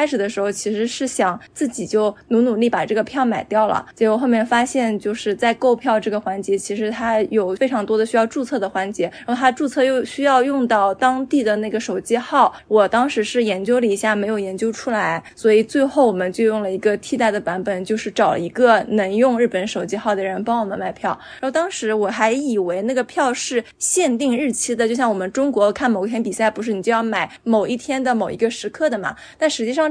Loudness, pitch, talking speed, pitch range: -19 LUFS, 225 Hz, 340 characters per minute, 210-250 Hz